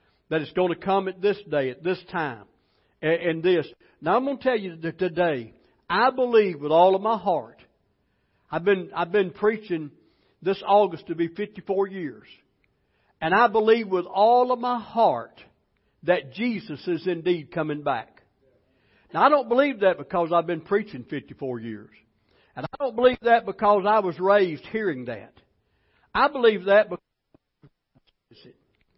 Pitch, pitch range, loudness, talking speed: 185 Hz, 160-215 Hz, -24 LUFS, 165 wpm